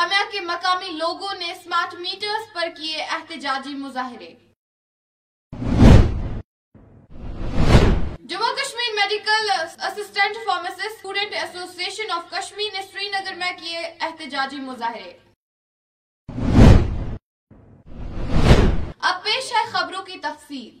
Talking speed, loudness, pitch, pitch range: 95 wpm, -21 LUFS, 365 Hz, 325-400 Hz